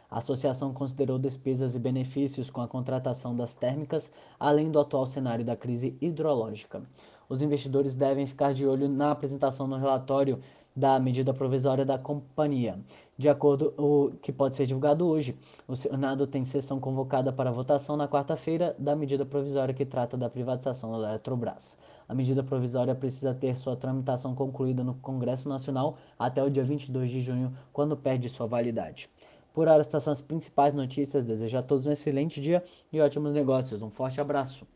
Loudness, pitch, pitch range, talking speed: -29 LUFS, 135 Hz, 130-145 Hz, 175 wpm